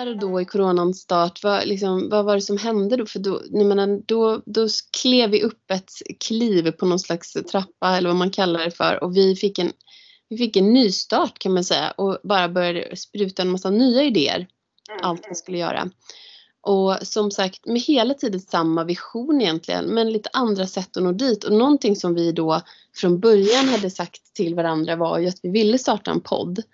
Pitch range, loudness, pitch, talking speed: 180-225 Hz, -21 LUFS, 195 Hz, 195 wpm